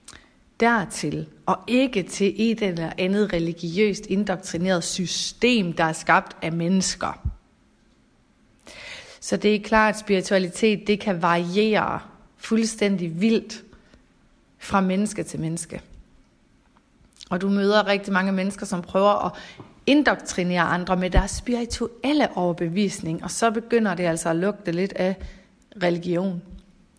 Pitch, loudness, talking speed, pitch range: 195 Hz, -23 LUFS, 120 wpm, 180-210 Hz